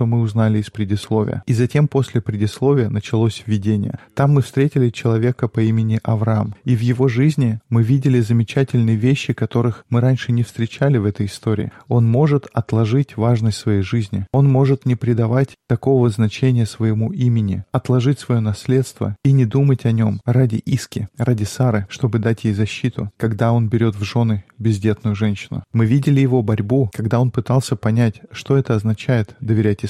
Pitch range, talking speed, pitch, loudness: 110-130 Hz, 165 wpm, 115 Hz, -18 LUFS